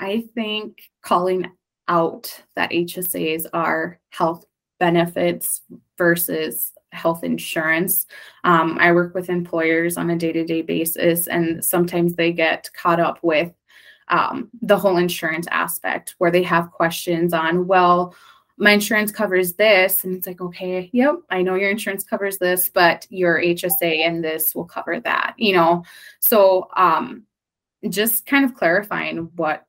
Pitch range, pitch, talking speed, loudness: 170-195 Hz, 175 Hz, 150 wpm, -19 LUFS